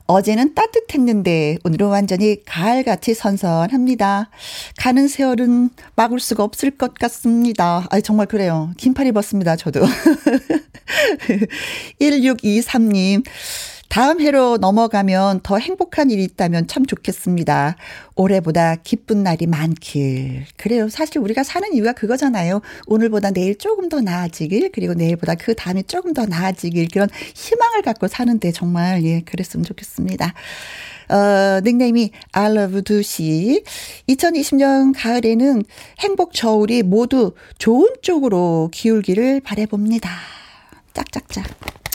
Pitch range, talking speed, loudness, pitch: 185-255 Hz, 285 characters per minute, -17 LUFS, 215 Hz